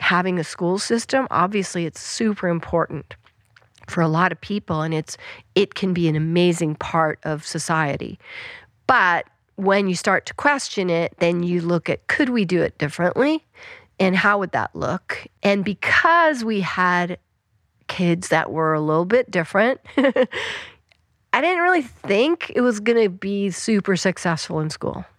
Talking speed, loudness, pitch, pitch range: 160 wpm, -20 LUFS, 180 Hz, 160-215 Hz